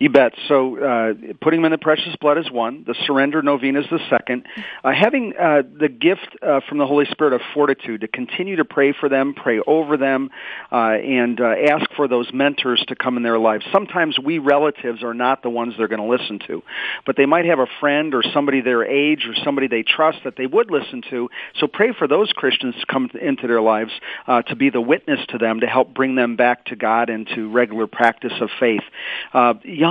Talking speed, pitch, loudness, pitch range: 230 wpm, 135 Hz, -18 LUFS, 120-145 Hz